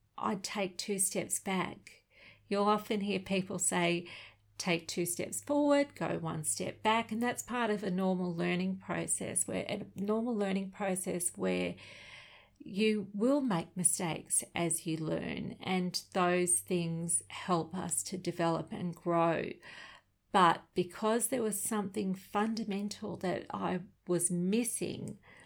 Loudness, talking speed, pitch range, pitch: -33 LUFS, 135 wpm, 175-210 Hz, 185 Hz